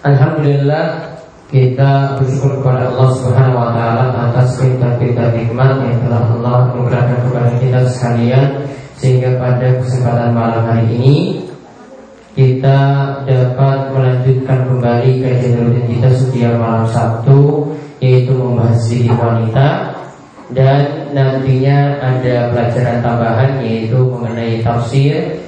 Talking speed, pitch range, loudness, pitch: 110 wpm, 120-135 Hz, -12 LUFS, 125 Hz